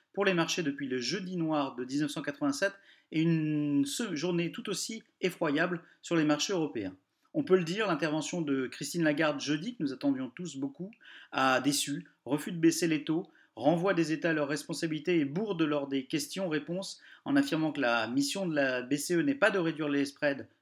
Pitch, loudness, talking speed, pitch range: 160 Hz, -31 LUFS, 185 wpm, 145-180 Hz